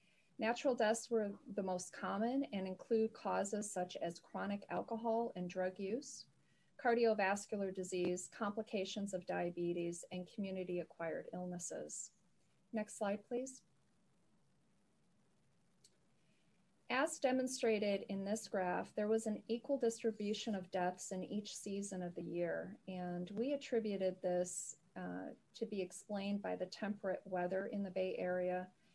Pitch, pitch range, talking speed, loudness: 200 Hz, 180-220 Hz, 130 wpm, -41 LUFS